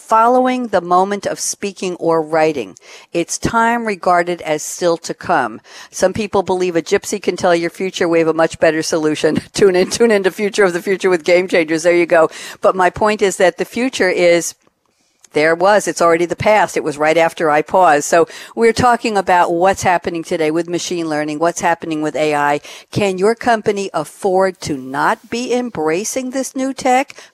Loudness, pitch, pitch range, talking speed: -15 LUFS, 180 Hz, 165-205 Hz, 195 wpm